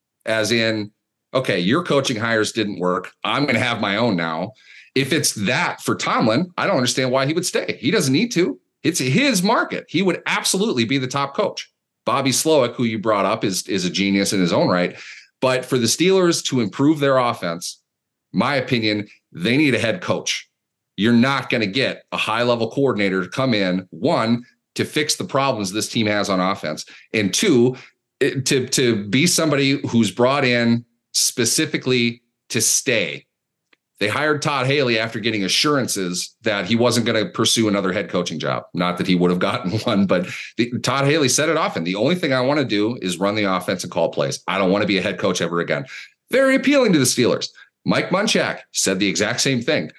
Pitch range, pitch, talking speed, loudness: 100-135 Hz, 115 Hz, 205 wpm, -19 LUFS